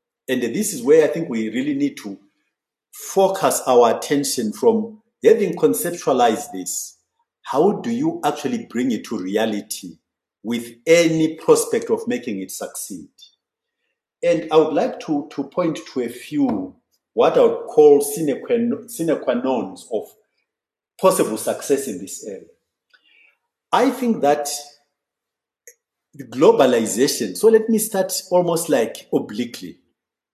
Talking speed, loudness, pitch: 140 wpm, -19 LUFS, 225 Hz